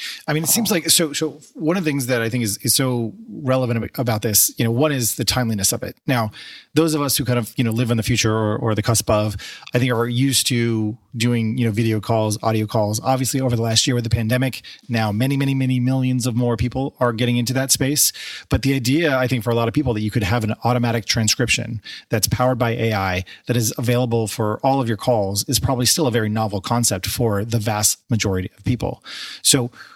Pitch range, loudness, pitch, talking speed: 115-130 Hz, -19 LUFS, 120 Hz, 245 wpm